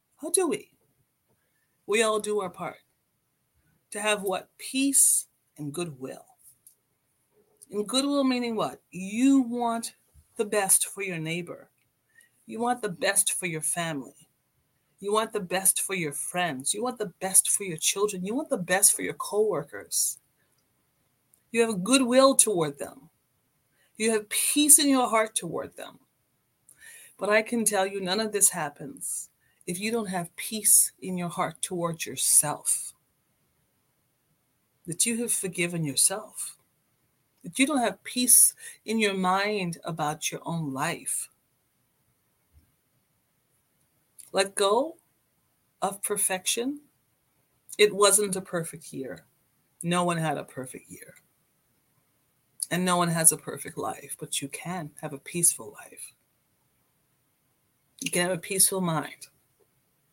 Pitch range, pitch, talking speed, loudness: 150-220 Hz, 185 Hz, 135 wpm, -25 LUFS